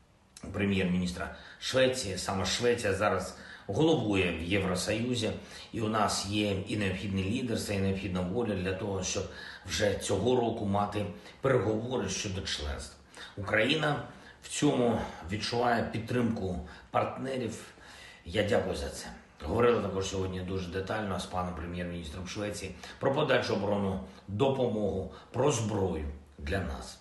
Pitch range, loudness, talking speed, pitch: 90-110 Hz, -31 LUFS, 120 wpm, 100 Hz